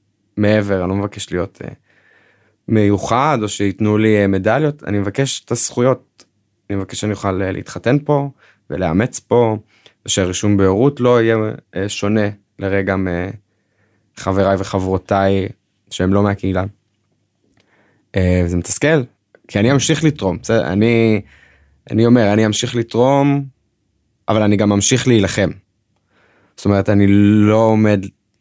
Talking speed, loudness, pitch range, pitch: 115 wpm, -16 LUFS, 95-115 Hz, 105 Hz